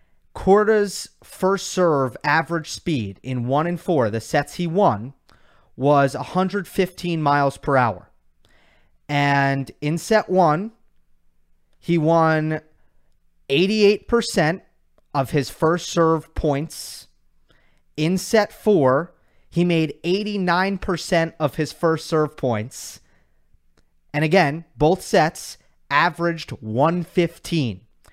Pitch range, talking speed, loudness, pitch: 135-175 Hz, 100 wpm, -21 LUFS, 155 Hz